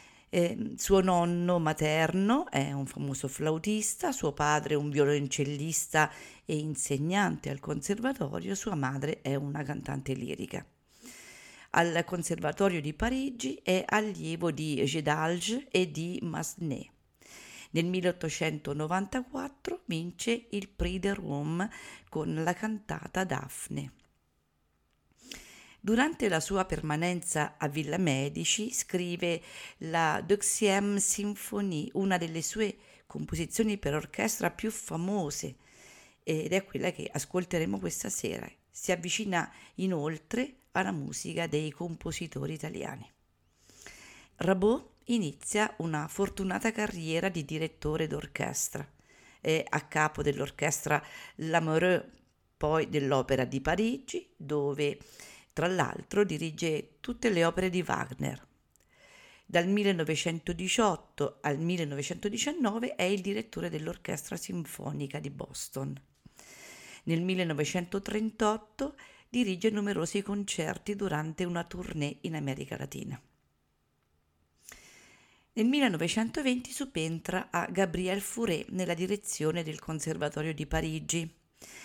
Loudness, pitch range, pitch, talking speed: -32 LUFS, 150-205 Hz, 170 Hz, 100 wpm